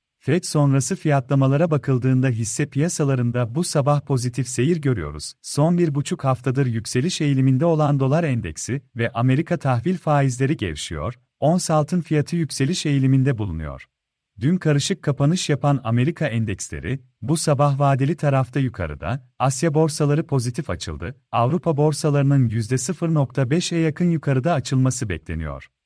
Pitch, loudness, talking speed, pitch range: 140 Hz, -21 LUFS, 120 wpm, 125-155 Hz